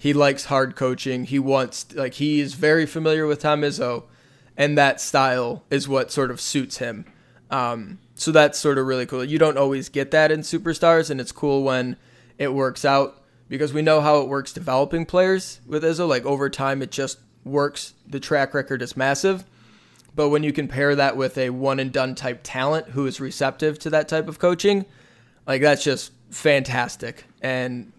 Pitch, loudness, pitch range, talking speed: 140 Hz, -21 LUFS, 130-150 Hz, 195 wpm